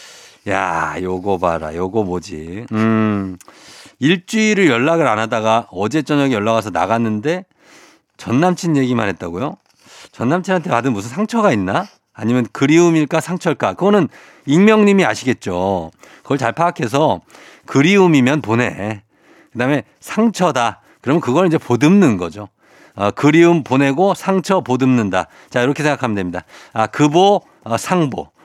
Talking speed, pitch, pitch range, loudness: 305 characters per minute, 125 Hz, 105-170 Hz, -16 LUFS